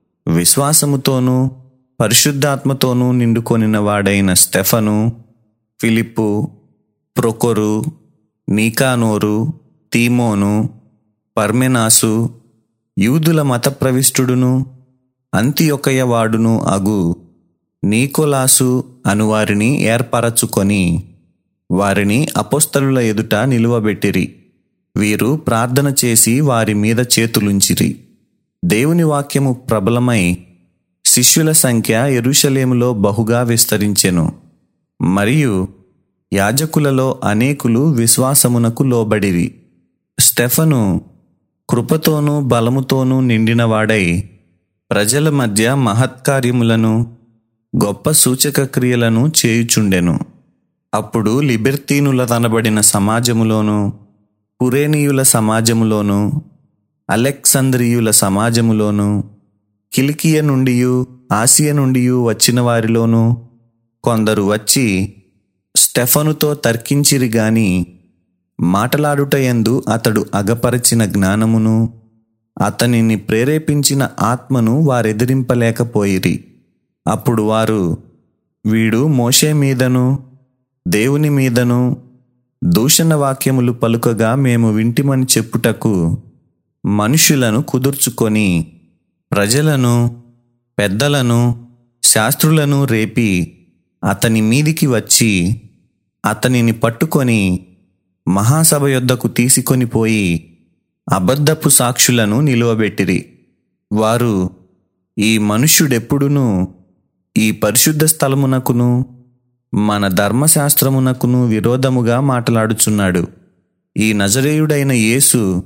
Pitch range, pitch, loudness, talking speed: 105-130 Hz, 120 Hz, -13 LUFS, 65 wpm